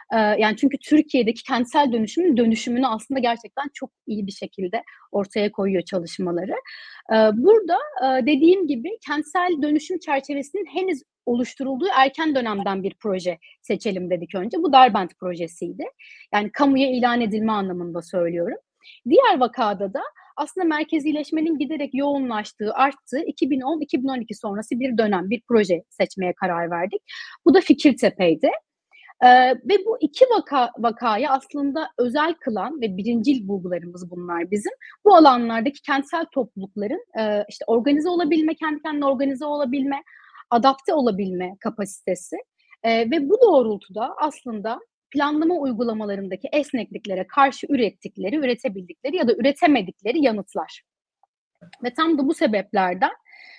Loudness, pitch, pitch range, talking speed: -21 LUFS, 260 Hz, 210-300 Hz, 120 wpm